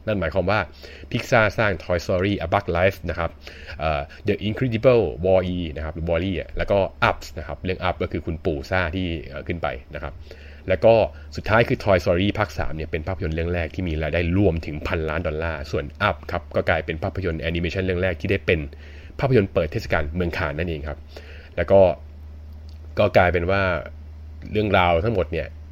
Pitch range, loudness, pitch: 75-95 Hz, -23 LUFS, 85 Hz